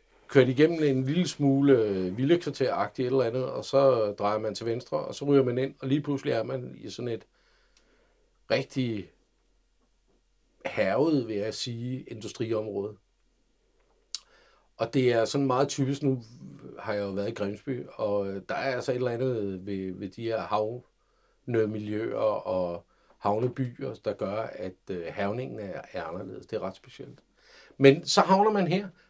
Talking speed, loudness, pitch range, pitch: 160 wpm, -28 LUFS, 105-140 Hz, 125 Hz